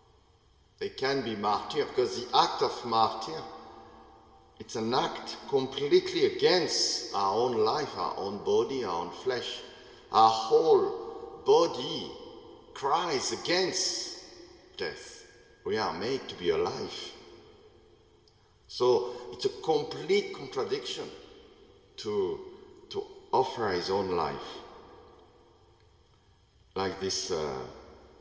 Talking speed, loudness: 100 wpm, -29 LUFS